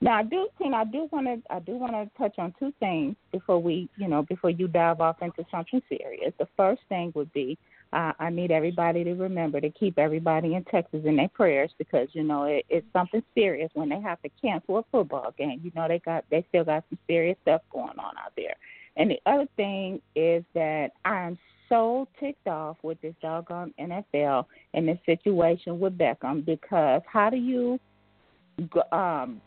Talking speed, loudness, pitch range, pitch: 205 wpm, -27 LUFS, 160-215 Hz, 175 Hz